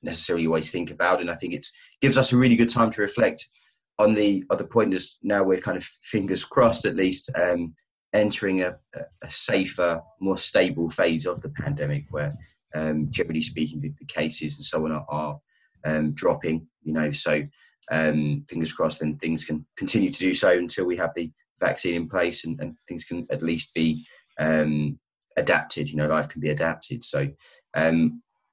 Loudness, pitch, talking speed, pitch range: -25 LUFS, 80 Hz, 190 wpm, 75-90 Hz